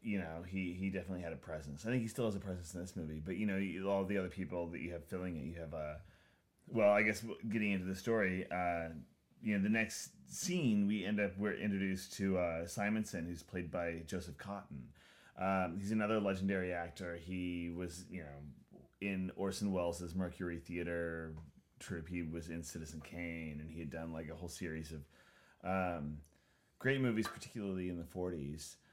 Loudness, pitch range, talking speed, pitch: -40 LUFS, 85-100 Hz, 200 wpm, 90 Hz